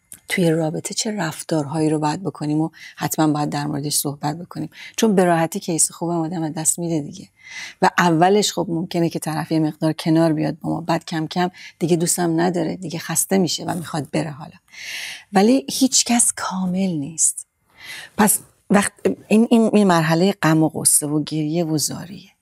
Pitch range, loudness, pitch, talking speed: 155-180 Hz, -19 LUFS, 165 Hz, 175 wpm